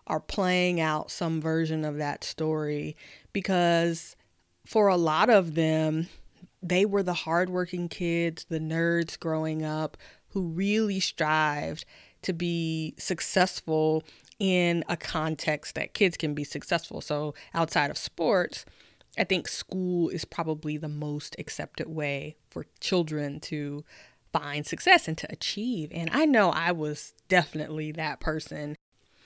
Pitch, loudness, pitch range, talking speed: 160 Hz, -28 LUFS, 150-175 Hz, 135 wpm